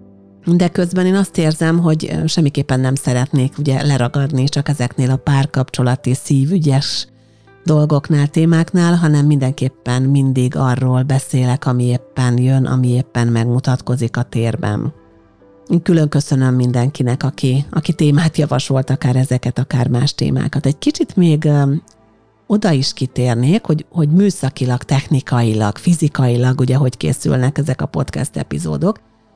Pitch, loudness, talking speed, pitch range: 135 Hz, -16 LUFS, 125 wpm, 125-150 Hz